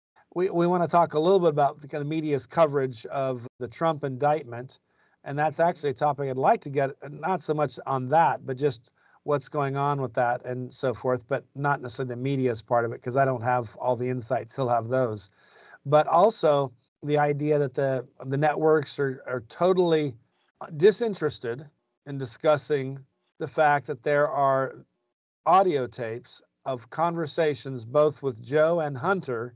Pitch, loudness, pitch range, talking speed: 140 Hz, -26 LUFS, 125-150 Hz, 180 wpm